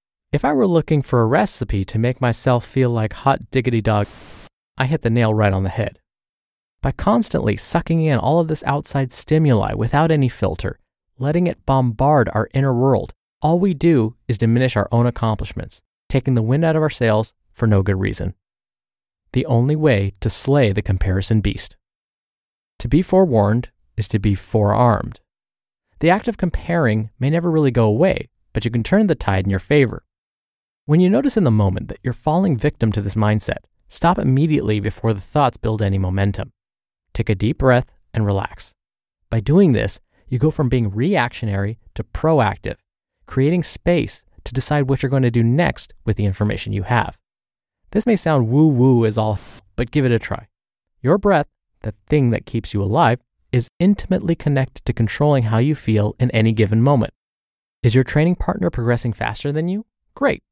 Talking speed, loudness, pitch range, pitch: 185 wpm, -18 LUFS, 110-145 Hz, 120 Hz